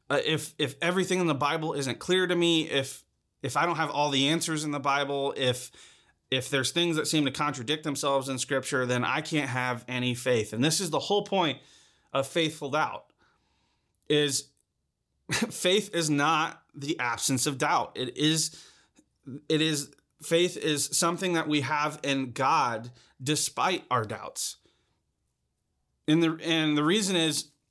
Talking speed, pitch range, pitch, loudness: 165 wpm, 135-160 Hz, 150 Hz, -27 LUFS